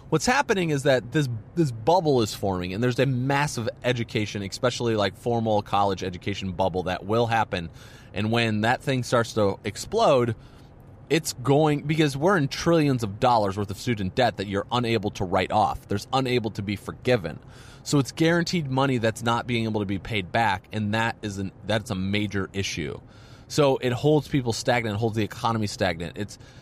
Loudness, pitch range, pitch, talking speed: -25 LUFS, 105-130 Hz, 115 Hz, 190 wpm